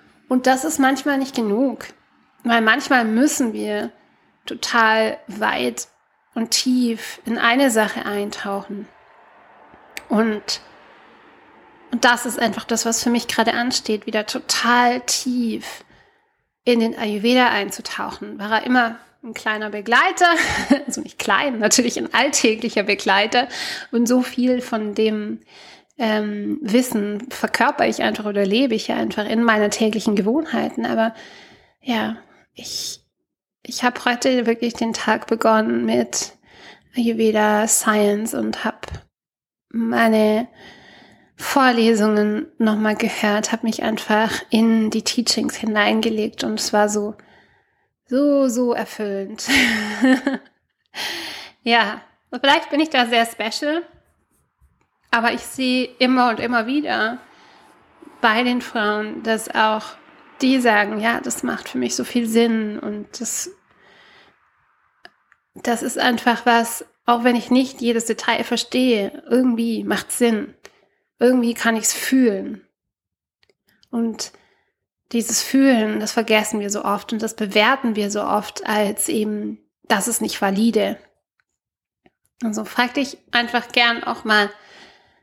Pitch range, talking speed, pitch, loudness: 215-250 Hz, 125 wpm, 230 Hz, -19 LUFS